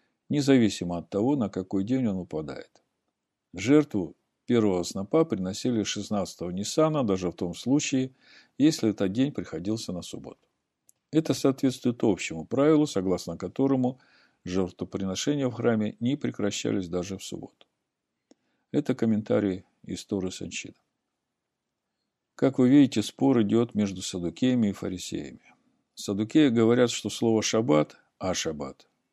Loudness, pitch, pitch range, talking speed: -27 LUFS, 110 Hz, 95-130 Hz, 120 wpm